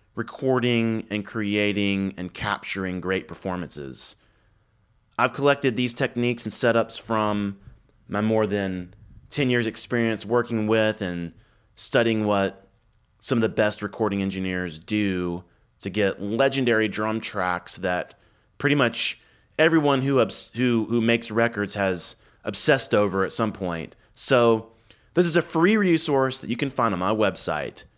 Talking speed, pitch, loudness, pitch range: 140 wpm, 110 Hz, -24 LUFS, 100-120 Hz